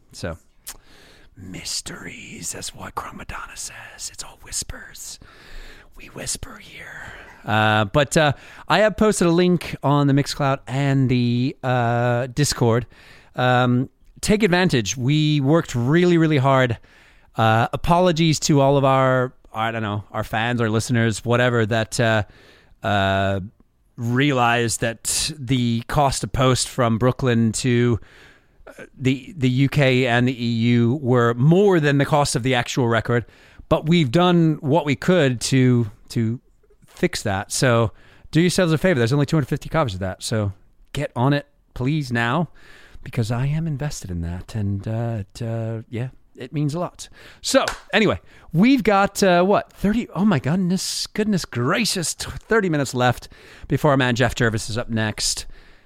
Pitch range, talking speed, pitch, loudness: 115-150 Hz, 150 wpm, 125 Hz, -20 LUFS